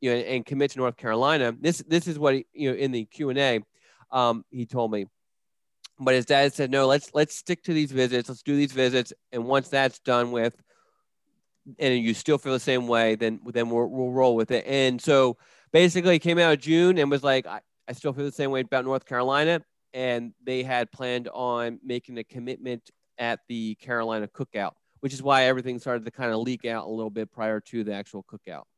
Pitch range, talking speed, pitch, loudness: 120-140 Hz, 225 wpm, 130 Hz, -25 LUFS